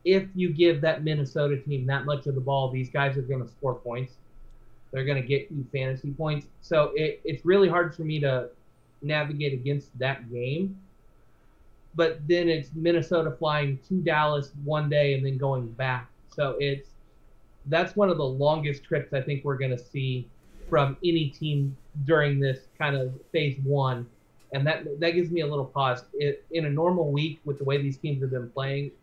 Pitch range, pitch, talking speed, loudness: 135-155 Hz, 140 Hz, 195 wpm, -27 LUFS